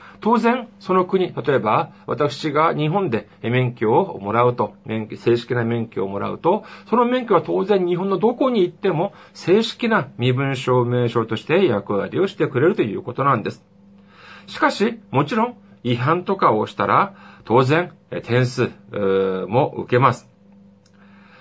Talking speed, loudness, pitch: 285 characters per minute, -20 LUFS, 130 Hz